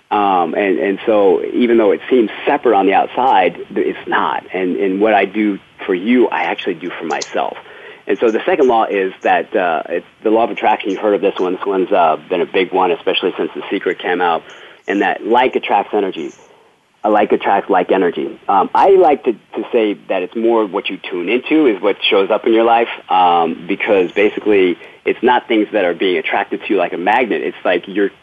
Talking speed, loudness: 225 wpm, -15 LUFS